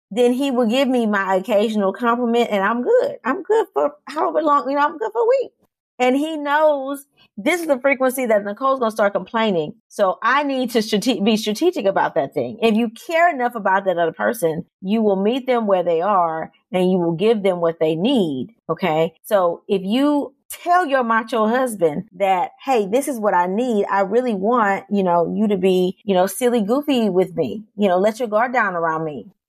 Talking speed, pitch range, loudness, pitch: 215 wpm, 195-260 Hz, -19 LUFS, 225 Hz